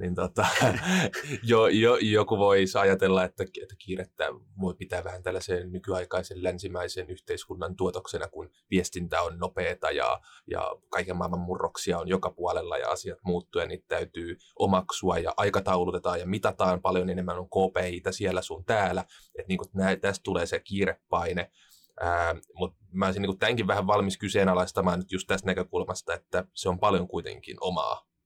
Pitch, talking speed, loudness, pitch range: 95 Hz, 155 wpm, -28 LUFS, 90-100 Hz